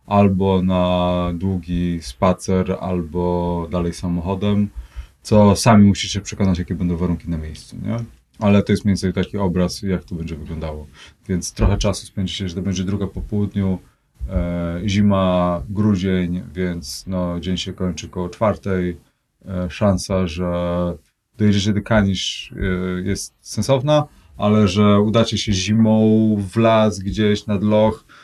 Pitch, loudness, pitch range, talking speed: 95 Hz, -19 LUFS, 90-105 Hz, 140 wpm